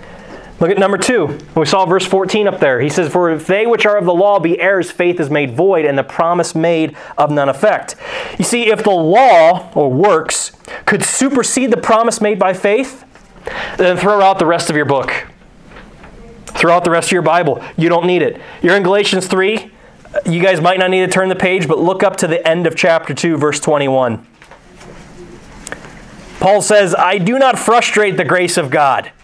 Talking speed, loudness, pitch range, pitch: 205 wpm, -13 LUFS, 165-205 Hz, 185 Hz